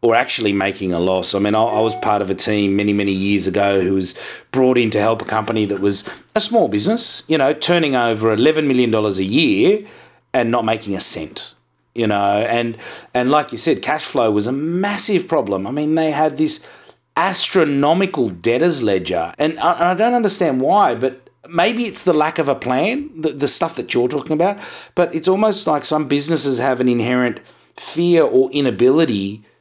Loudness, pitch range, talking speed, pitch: -17 LUFS, 105-160 Hz, 205 wpm, 125 Hz